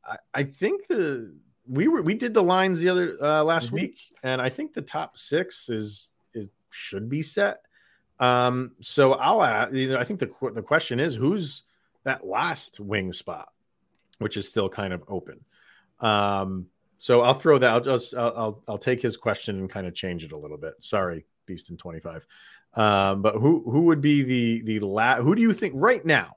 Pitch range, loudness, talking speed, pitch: 105-155 Hz, -24 LUFS, 205 wpm, 125 Hz